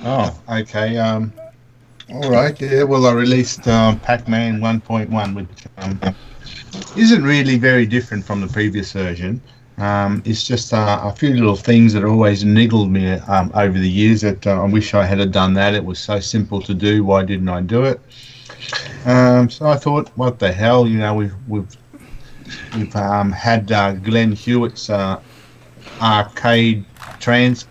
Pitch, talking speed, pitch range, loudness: 110 Hz, 170 wpm, 100-125 Hz, -16 LUFS